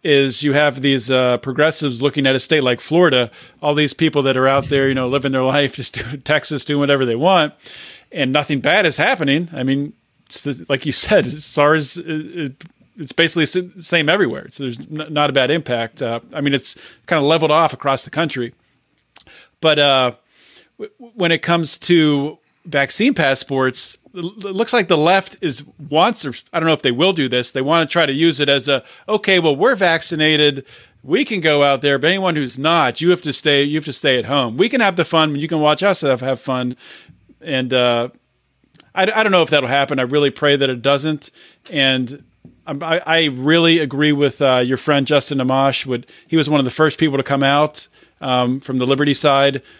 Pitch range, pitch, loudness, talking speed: 135-160 Hz, 145 Hz, -16 LUFS, 215 wpm